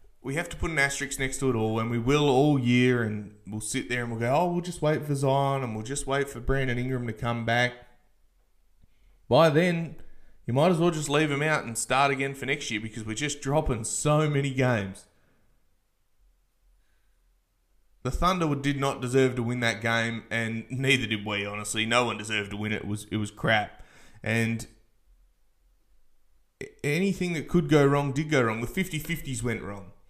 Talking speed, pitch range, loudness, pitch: 200 wpm, 105-140 Hz, -27 LUFS, 125 Hz